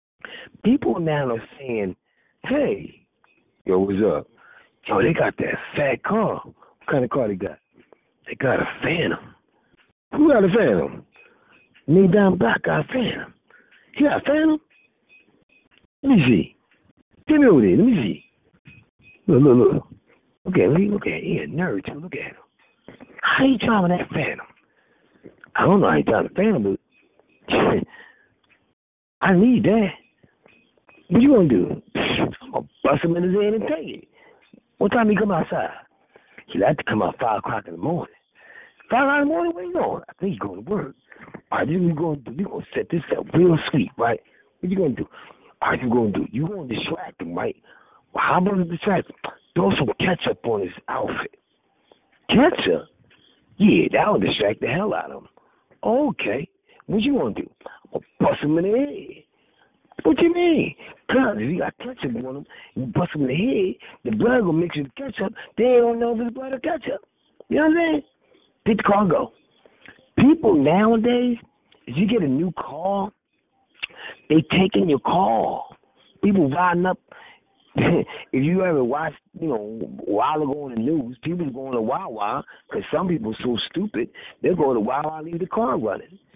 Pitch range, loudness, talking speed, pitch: 165-260 Hz, -21 LUFS, 195 wpm, 200 Hz